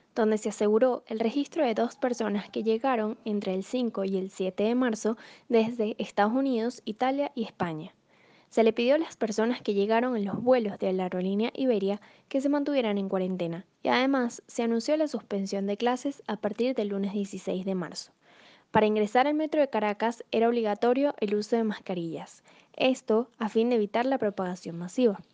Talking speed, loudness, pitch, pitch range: 185 wpm, -28 LUFS, 225 Hz, 205-250 Hz